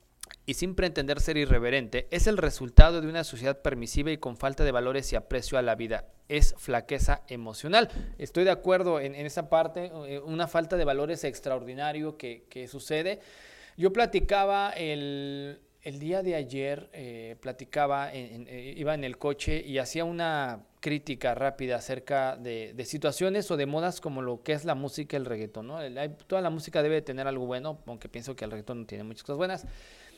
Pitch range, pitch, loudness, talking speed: 130-165 Hz, 145 Hz, -30 LUFS, 190 wpm